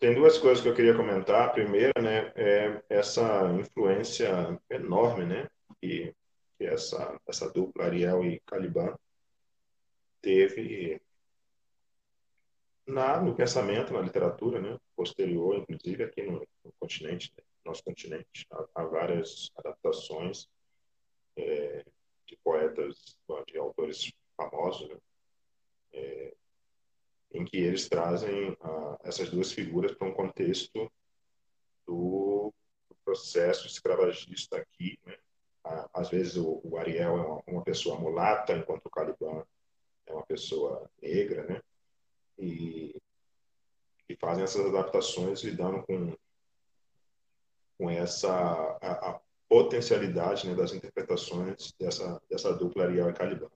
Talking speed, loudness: 120 wpm, -30 LUFS